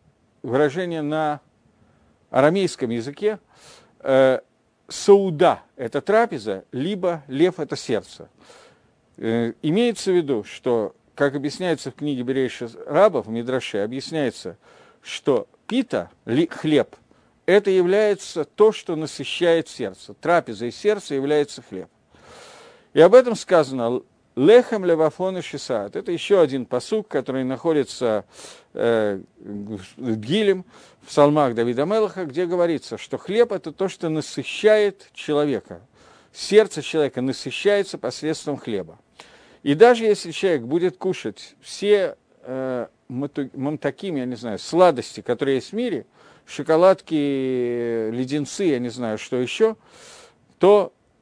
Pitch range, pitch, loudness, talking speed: 130-195 Hz, 150 Hz, -21 LUFS, 120 wpm